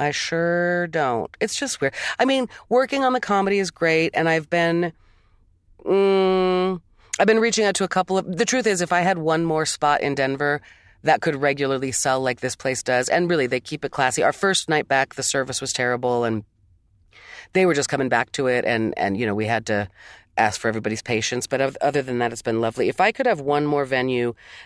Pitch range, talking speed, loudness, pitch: 125-185 Hz, 230 wpm, -21 LUFS, 145 Hz